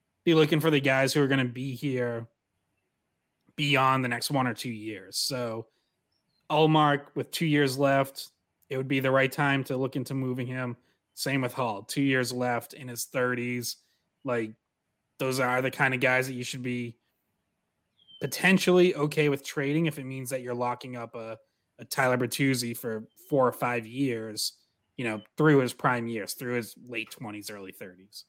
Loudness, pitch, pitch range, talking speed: -27 LUFS, 130 Hz, 120-140 Hz, 185 wpm